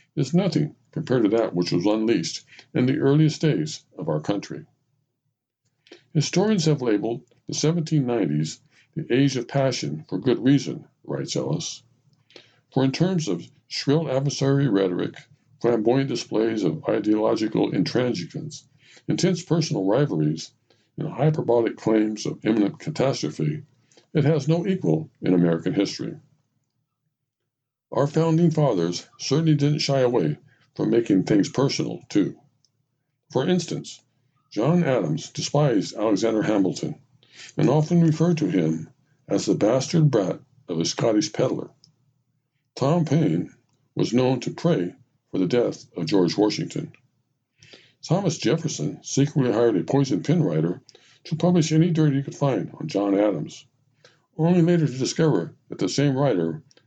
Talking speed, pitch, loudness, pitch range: 135 wpm, 140 Hz, -23 LUFS, 120-155 Hz